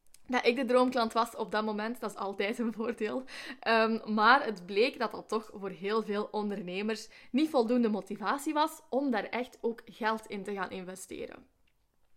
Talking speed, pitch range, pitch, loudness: 185 wpm, 210-245 Hz, 225 Hz, -31 LUFS